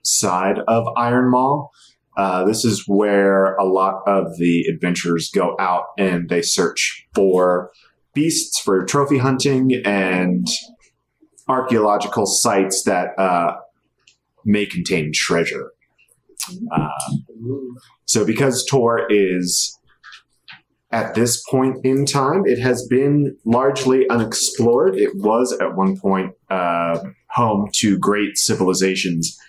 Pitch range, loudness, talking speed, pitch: 95-130 Hz, -18 LUFS, 115 wpm, 105 Hz